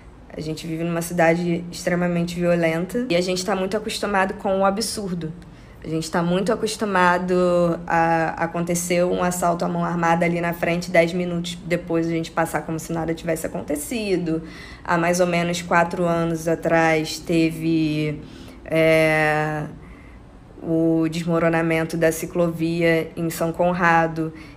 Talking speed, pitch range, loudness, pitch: 140 wpm, 165-175 Hz, -21 LUFS, 170 Hz